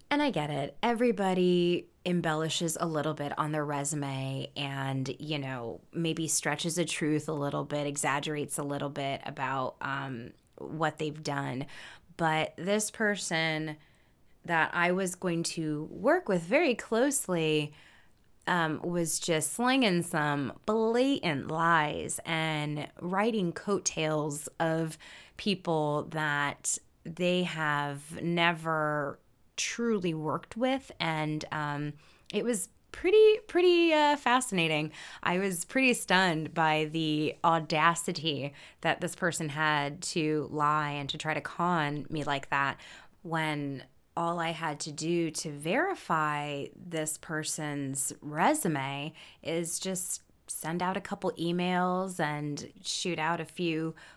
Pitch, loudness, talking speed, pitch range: 160 Hz, -30 LUFS, 125 wpm, 150-180 Hz